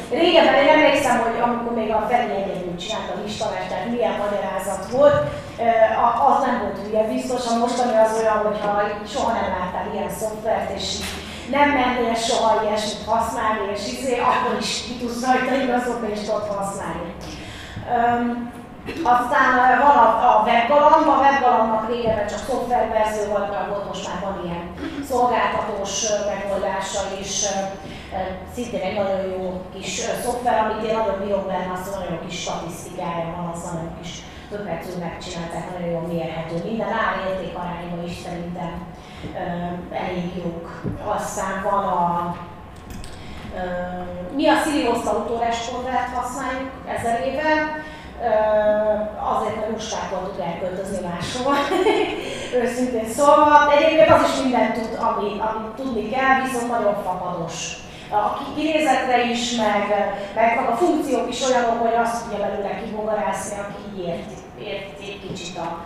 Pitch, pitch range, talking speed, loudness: 210 Hz, 185-240 Hz, 140 wpm, -21 LUFS